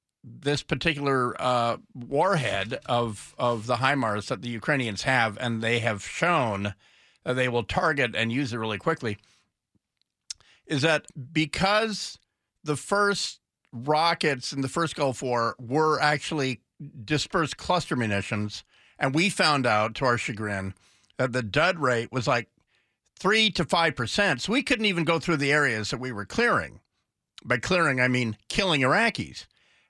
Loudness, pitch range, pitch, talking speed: -25 LUFS, 115-155 Hz, 130 Hz, 150 wpm